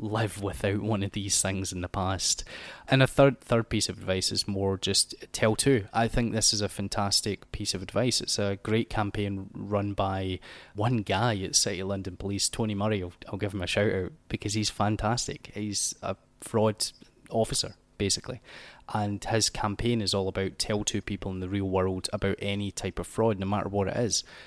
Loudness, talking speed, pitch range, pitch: -28 LUFS, 205 wpm, 95-110 Hz, 100 Hz